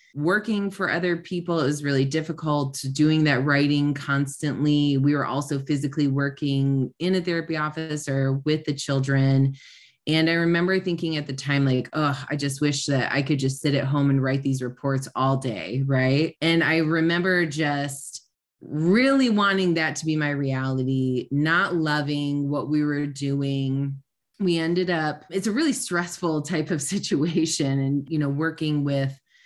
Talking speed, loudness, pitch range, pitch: 165 wpm, -24 LUFS, 140-165 Hz, 145 Hz